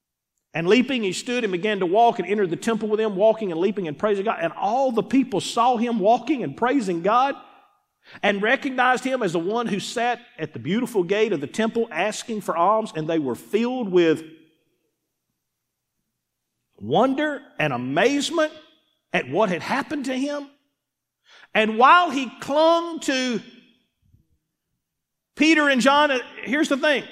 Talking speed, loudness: 160 wpm, -22 LUFS